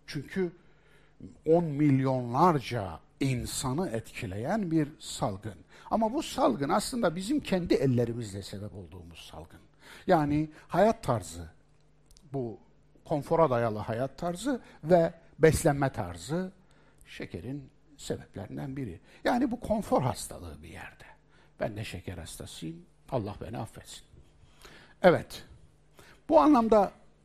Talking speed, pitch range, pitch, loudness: 105 wpm, 115-180 Hz, 145 Hz, -29 LUFS